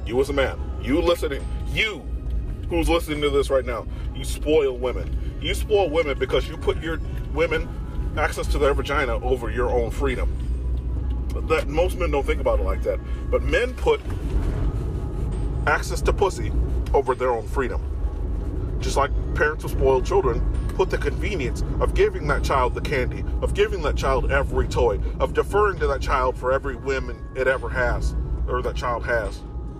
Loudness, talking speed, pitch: -24 LUFS, 175 wpm, 130 Hz